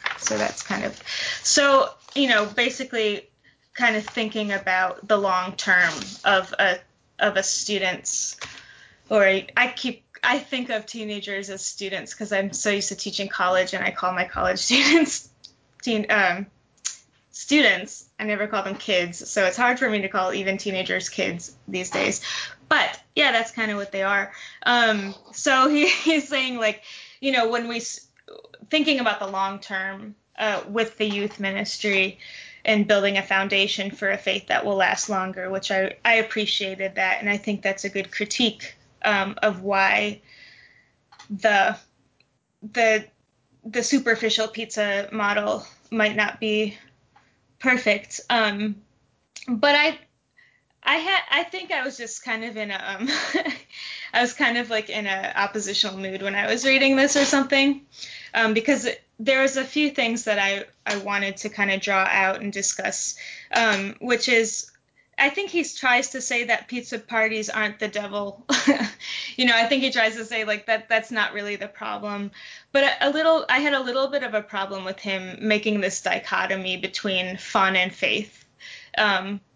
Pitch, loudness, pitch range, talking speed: 215 Hz, -22 LUFS, 195-245 Hz, 170 wpm